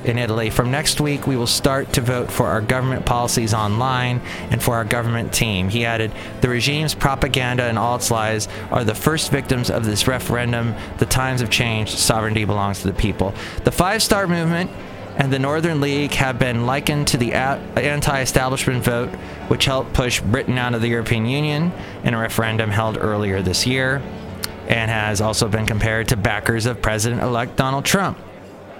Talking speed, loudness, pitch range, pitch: 185 wpm, -19 LUFS, 110-130 Hz, 120 Hz